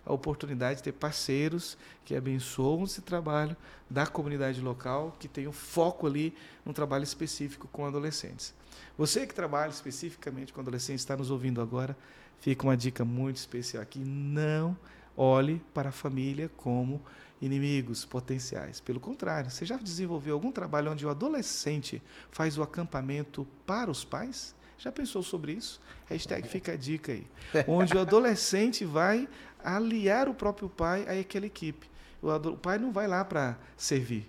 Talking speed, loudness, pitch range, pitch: 155 wpm, -32 LUFS, 135-180 Hz, 150 Hz